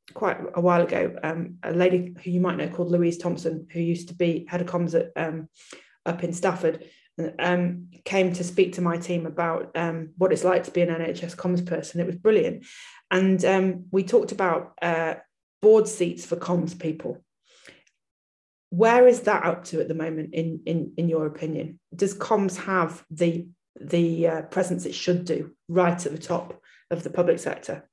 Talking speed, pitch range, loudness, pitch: 190 wpm, 165-180 Hz, -25 LUFS, 175 Hz